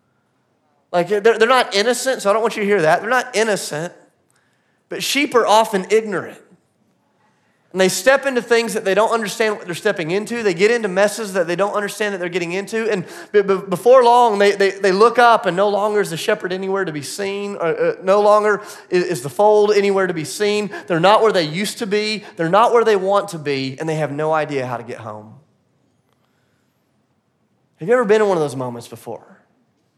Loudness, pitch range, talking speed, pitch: -17 LUFS, 175-220 Hz, 210 wpm, 200 Hz